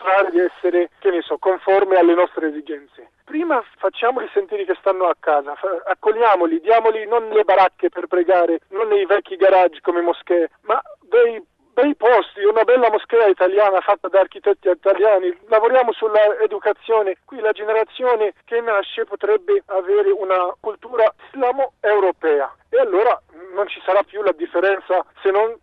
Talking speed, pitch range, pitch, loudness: 150 wpm, 185-230 Hz, 205 Hz, -18 LUFS